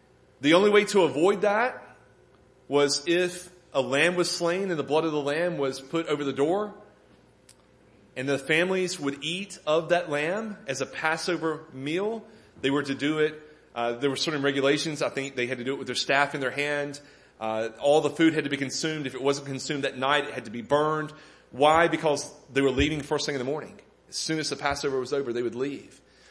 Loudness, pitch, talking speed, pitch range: -26 LUFS, 145 Hz, 220 wpm, 135-160 Hz